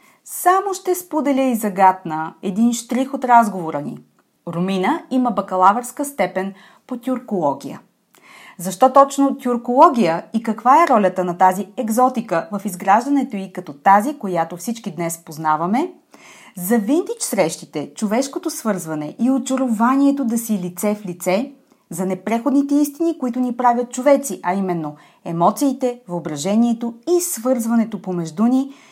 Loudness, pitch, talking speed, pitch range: -19 LUFS, 230 Hz, 130 wpm, 185-265 Hz